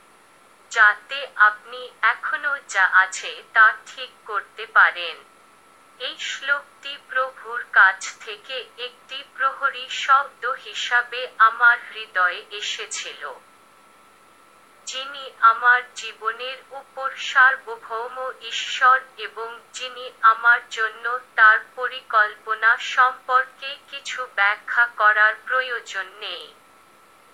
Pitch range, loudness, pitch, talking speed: 220-260 Hz, -20 LUFS, 240 Hz, 85 wpm